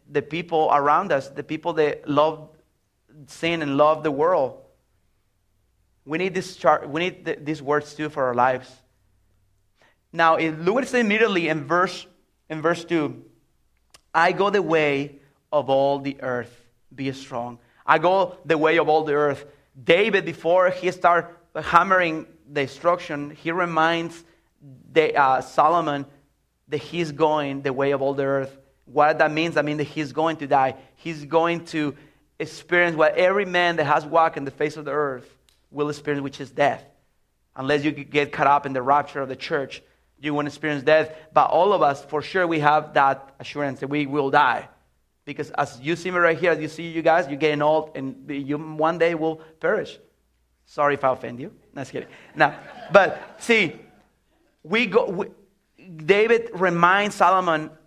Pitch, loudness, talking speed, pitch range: 150 Hz, -22 LUFS, 180 wpm, 140-165 Hz